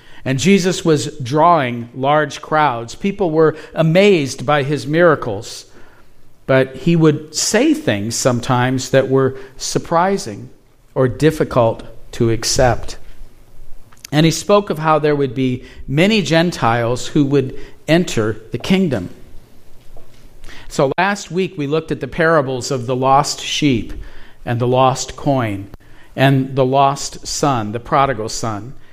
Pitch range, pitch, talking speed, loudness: 125-155 Hz, 135 Hz, 130 wpm, -16 LUFS